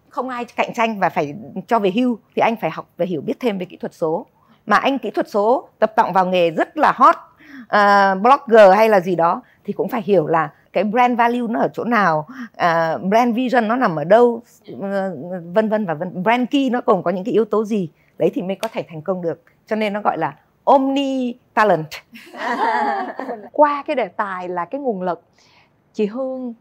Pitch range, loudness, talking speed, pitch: 185-245 Hz, -18 LUFS, 220 wpm, 220 Hz